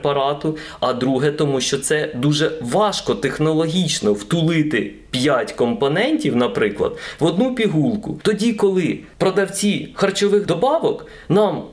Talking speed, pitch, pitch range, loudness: 115 wpm, 165 Hz, 145-205 Hz, -19 LUFS